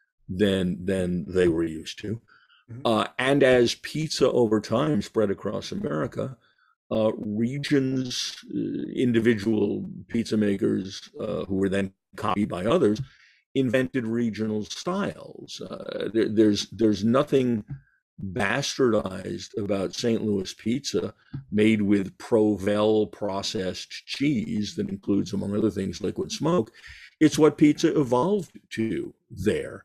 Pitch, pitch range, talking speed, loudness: 110 Hz, 100-125 Hz, 120 wpm, -25 LUFS